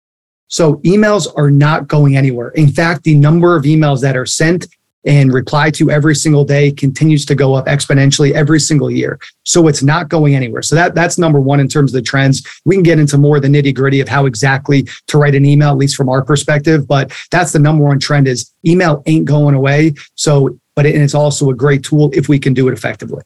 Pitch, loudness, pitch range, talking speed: 145 Hz, -11 LUFS, 140-155 Hz, 230 wpm